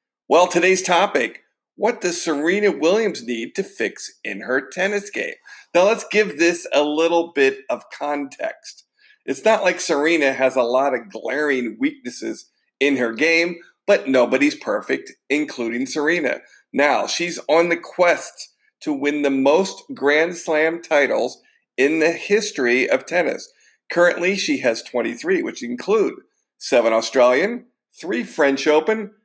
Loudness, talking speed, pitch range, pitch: -20 LUFS, 140 wpm, 145-220 Hz, 175 Hz